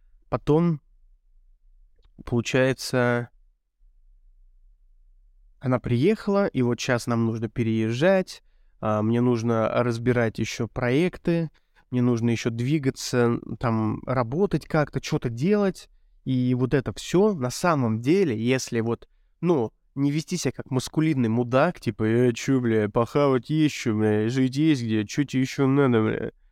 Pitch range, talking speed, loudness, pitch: 110-145 Hz, 125 wpm, -24 LUFS, 125 Hz